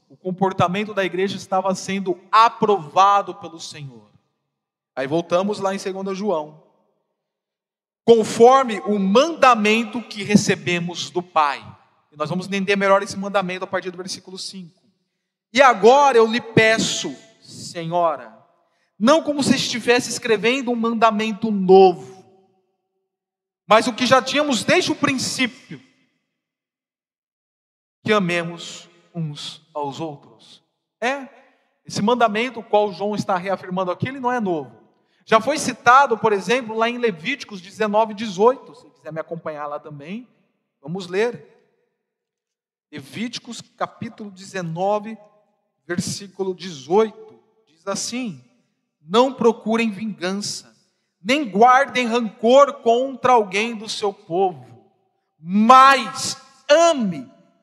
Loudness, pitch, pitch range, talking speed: -19 LUFS, 205 Hz, 185-235 Hz, 115 wpm